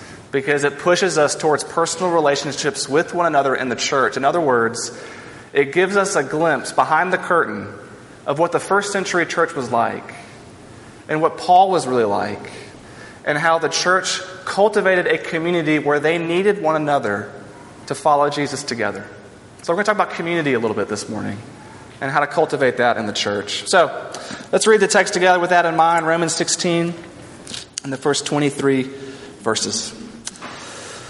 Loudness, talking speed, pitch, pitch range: -18 LUFS, 175 wpm, 155 Hz, 135-175 Hz